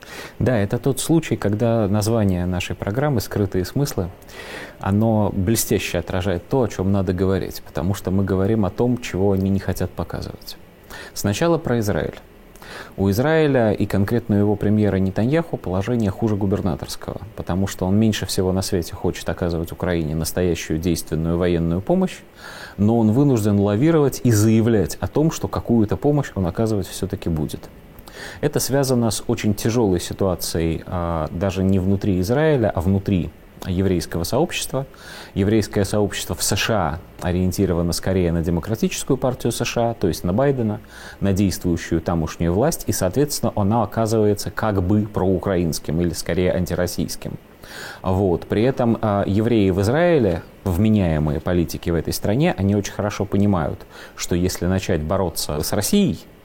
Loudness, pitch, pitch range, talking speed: -21 LUFS, 100 Hz, 90-115 Hz, 145 wpm